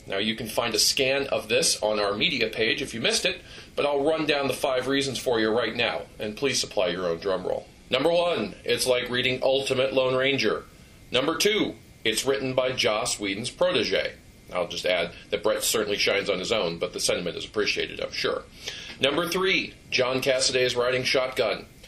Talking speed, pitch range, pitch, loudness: 205 wpm, 120-175 Hz, 130 Hz, -25 LUFS